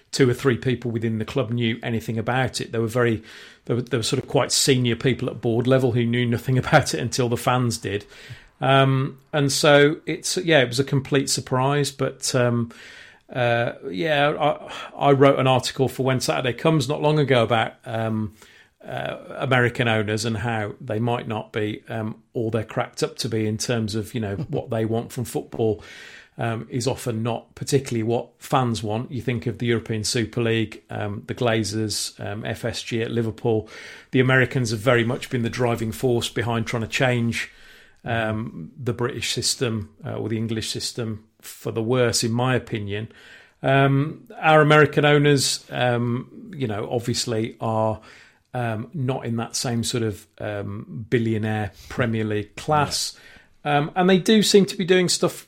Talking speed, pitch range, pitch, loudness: 185 wpm, 115-135 Hz, 120 Hz, -22 LUFS